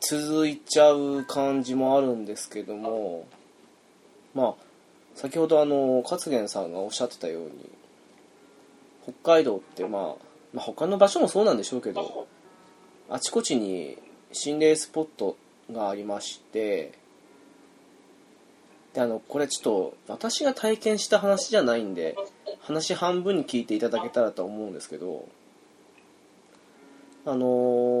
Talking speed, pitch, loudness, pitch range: 265 characters per minute, 145 Hz, -26 LUFS, 120-185 Hz